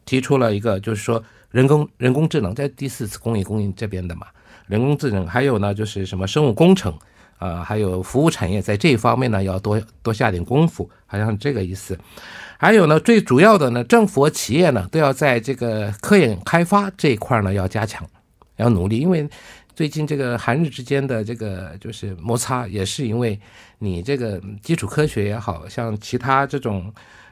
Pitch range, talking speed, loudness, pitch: 100-140 Hz, 300 characters per minute, -19 LUFS, 115 Hz